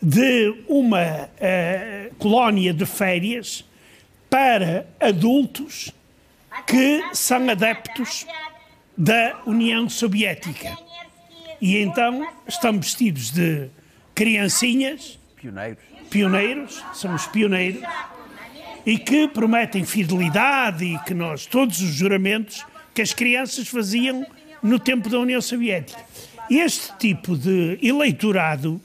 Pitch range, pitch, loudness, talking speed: 190-255 Hz, 225 Hz, -20 LUFS, 100 wpm